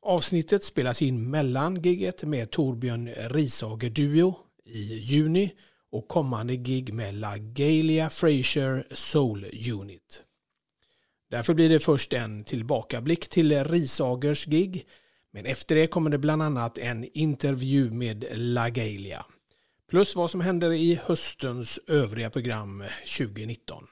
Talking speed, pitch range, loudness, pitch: 120 wpm, 120-160 Hz, -26 LUFS, 140 Hz